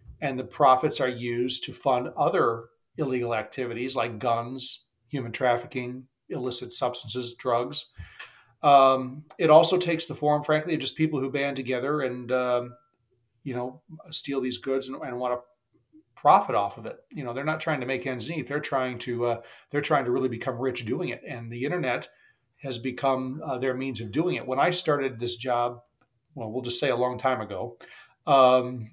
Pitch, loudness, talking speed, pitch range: 130 Hz, -26 LUFS, 190 wpm, 120-140 Hz